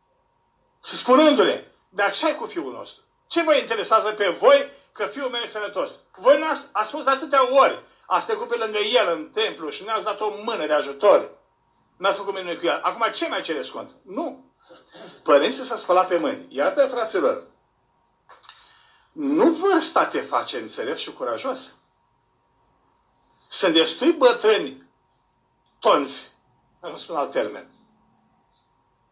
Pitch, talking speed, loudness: 280 Hz, 155 wpm, -22 LUFS